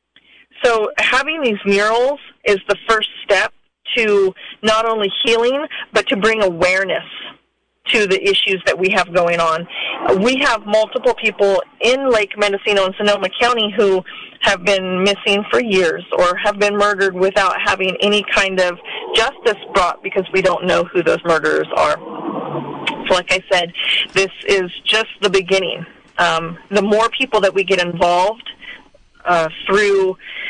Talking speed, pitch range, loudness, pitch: 155 wpm, 185-225 Hz, -16 LUFS, 205 Hz